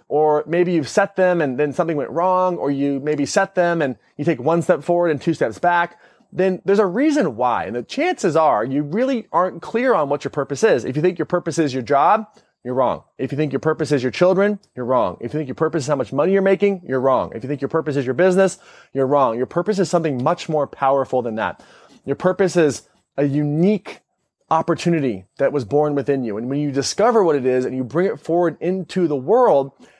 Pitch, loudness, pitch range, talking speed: 155 Hz, -19 LUFS, 140-180 Hz, 240 wpm